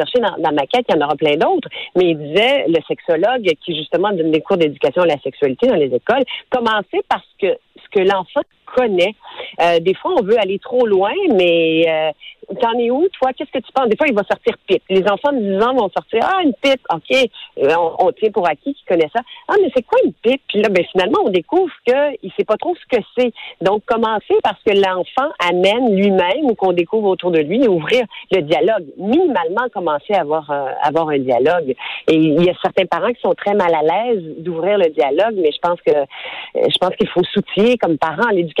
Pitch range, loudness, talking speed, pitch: 175-275 Hz, -16 LUFS, 235 wpm, 210 Hz